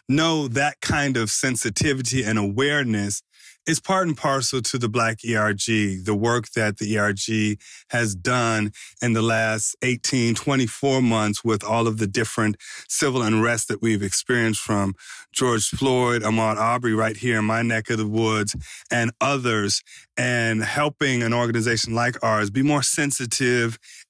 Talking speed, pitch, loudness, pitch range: 155 wpm, 115 Hz, -22 LUFS, 110-130 Hz